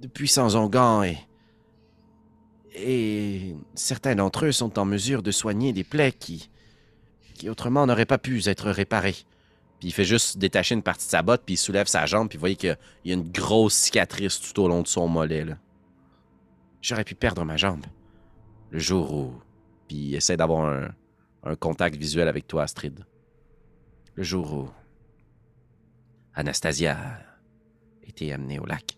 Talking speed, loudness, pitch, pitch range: 170 wpm, -24 LUFS, 100 Hz, 85-115 Hz